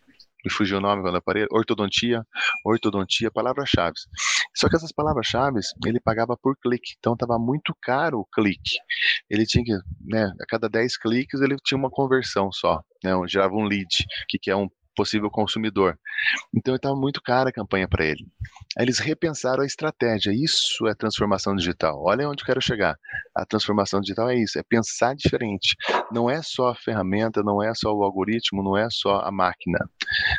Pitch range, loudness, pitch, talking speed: 100-130 Hz, -23 LUFS, 115 Hz, 180 wpm